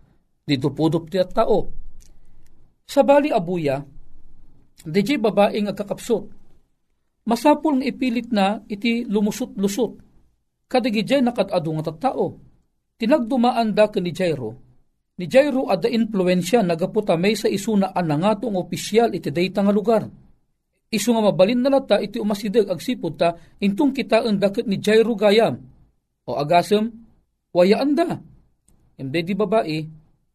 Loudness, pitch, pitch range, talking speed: -20 LUFS, 210 Hz, 175-235 Hz, 125 wpm